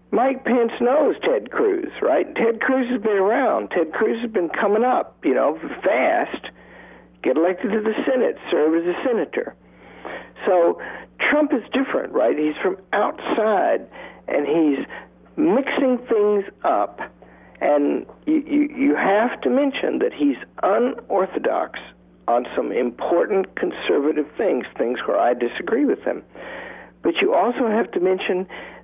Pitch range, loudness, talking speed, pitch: 190-280 Hz, -21 LUFS, 145 wpm, 235 Hz